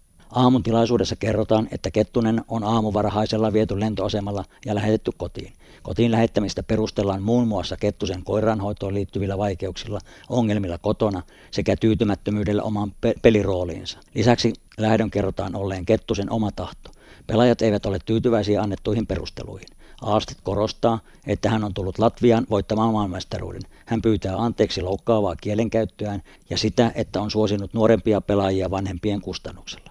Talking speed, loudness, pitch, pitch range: 125 wpm, -23 LUFS, 105 Hz, 95-110 Hz